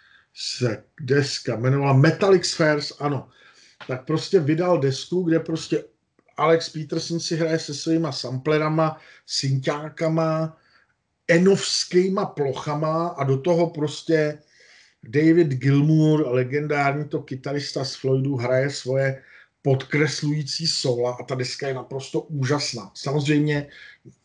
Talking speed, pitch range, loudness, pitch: 110 wpm, 135-160 Hz, -23 LUFS, 150 Hz